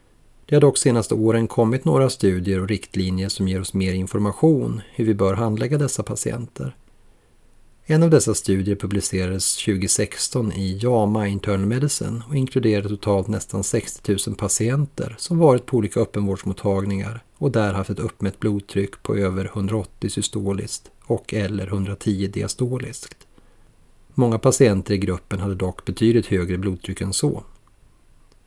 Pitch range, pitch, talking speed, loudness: 95-115 Hz, 105 Hz, 145 wpm, -21 LUFS